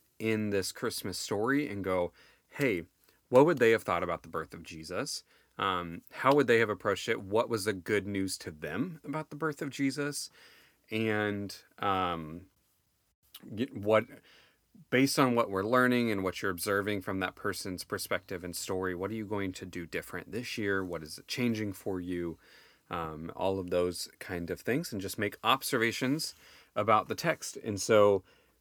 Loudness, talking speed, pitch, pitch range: -31 LUFS, 180 wpm, 100 Hz, 95-115 Hz